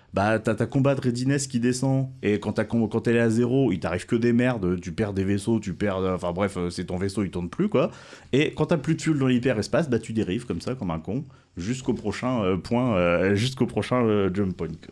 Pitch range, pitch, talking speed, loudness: 95-125 Hz, 110 Hz, 245 wpm, -25 LUFS